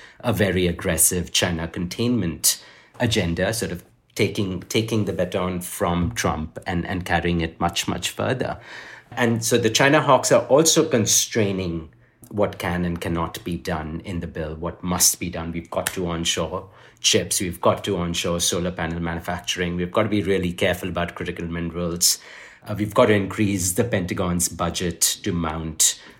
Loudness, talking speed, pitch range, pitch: -22 LUFS, 165 wpm, 85-105 Hz, 90 Hz